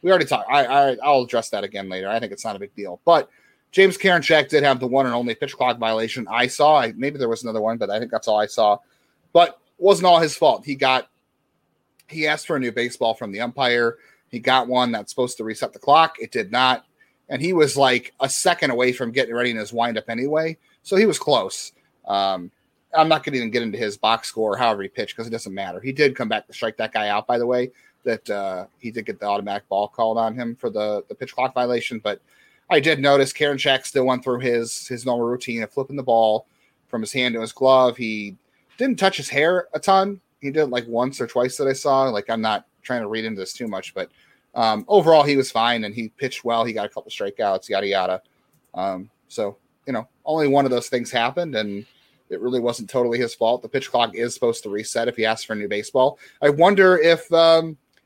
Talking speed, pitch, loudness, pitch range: 250 wpm, 125 Hz, -21 LUFS, 115-145 Hz